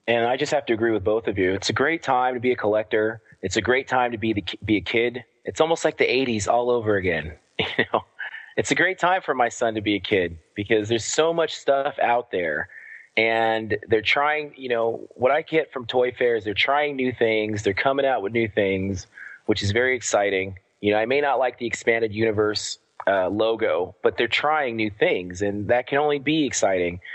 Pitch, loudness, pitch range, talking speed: 115 Hz, -23 LUFS, 105-130 Hz, 230 wpm